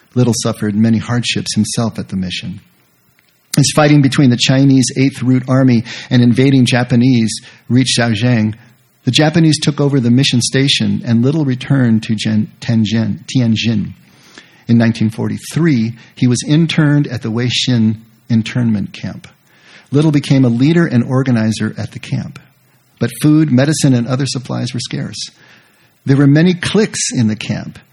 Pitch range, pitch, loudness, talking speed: 115-135 Hz, 125 Hz, -13 LUFS, 145 wpm